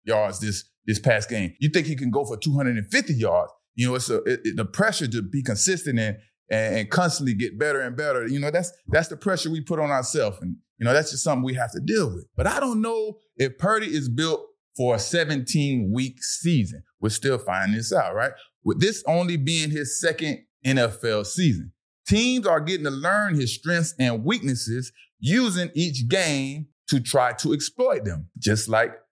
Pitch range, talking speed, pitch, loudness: 115-170 Hz, 205 wpm, 140 Hz, -24 LUFS